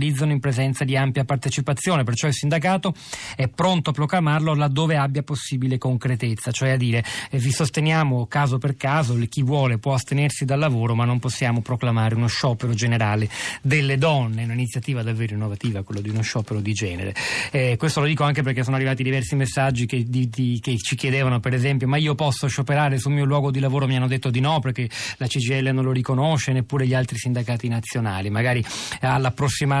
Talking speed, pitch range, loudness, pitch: 190 wpm, 120-145 Hz, -22 LUFS, 130 Hz